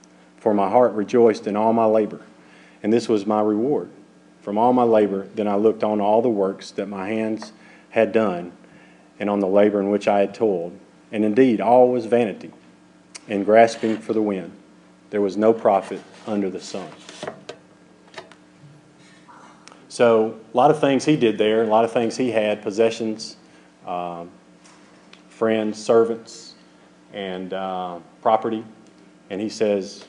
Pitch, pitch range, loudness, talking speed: 105 Hz, 90-115 Hz, -20 LUFS, 160 wpm